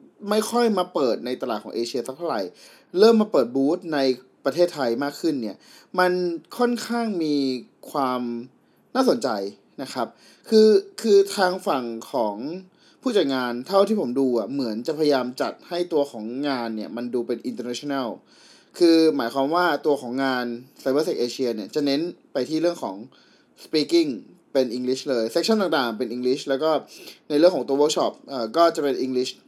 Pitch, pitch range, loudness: 145 Hz, 125-195 Hz, -23 LUFS